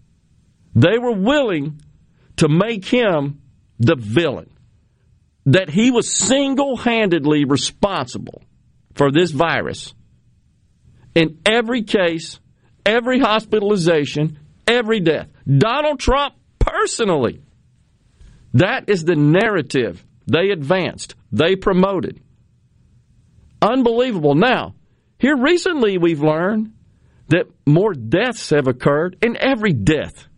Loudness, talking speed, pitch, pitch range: -17 LUFS, 95 wpm, 180 Hz, 145-235 Hz